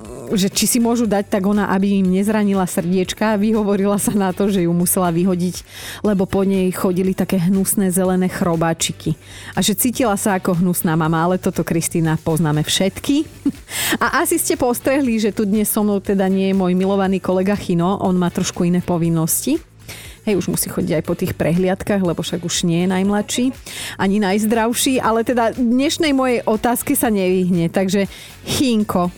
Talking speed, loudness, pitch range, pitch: 175 wpm, -18 LUFS, 180-215 Hz, 195 Hz